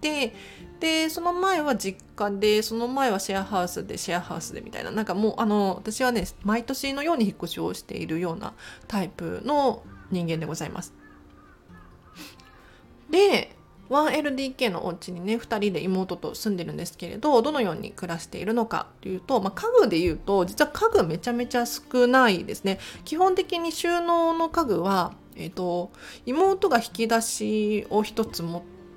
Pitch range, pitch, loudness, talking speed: 185-280 Hz, 220 Hz, -25 LUFS, 330 characters per minute